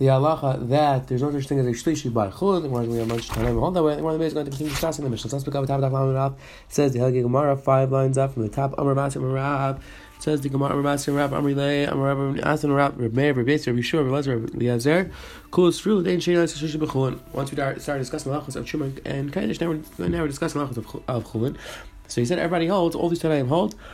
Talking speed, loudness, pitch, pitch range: 165 wpm, -23 LUFS, 140 Hz, 135-155 Hz